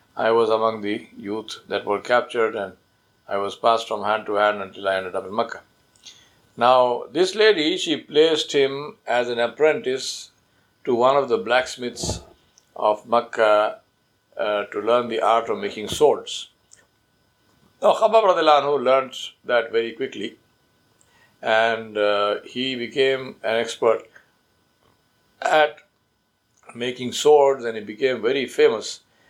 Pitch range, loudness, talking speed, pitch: 105-135 Hz, -21 LUFS, 135 wpm, 120 Hz